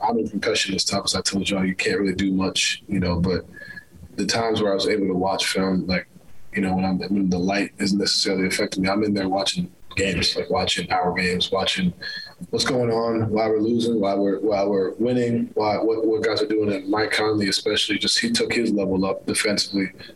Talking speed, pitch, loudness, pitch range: 230 wpm, 100 Hz, -22 LUFS, 95-110 Hz